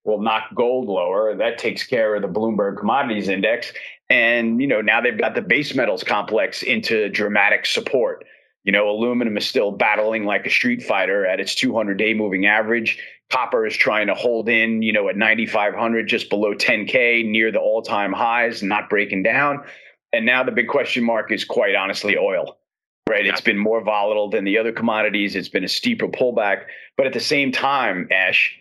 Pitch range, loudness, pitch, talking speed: 105-120 Hz, -19 LUFS, 110 Hz, 190 wpm